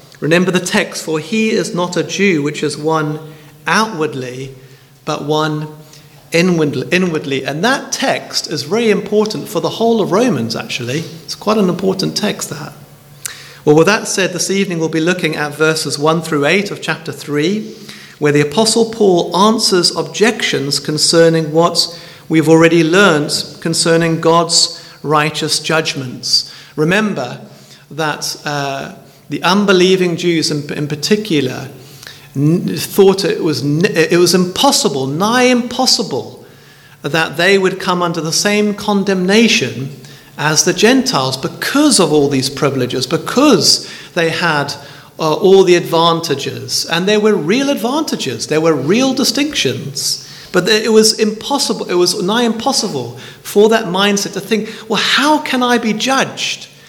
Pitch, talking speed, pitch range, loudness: 170 Hz, 140 wpm, 150-205 Hz, -13 LUFS